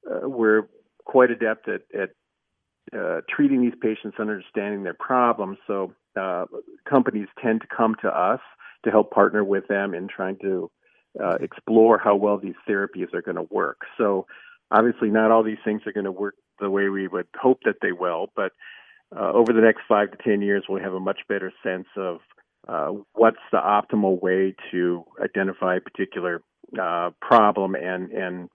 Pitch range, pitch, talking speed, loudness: 95-110 Hz, 105 Hz, 185 wpm, -23 LUFS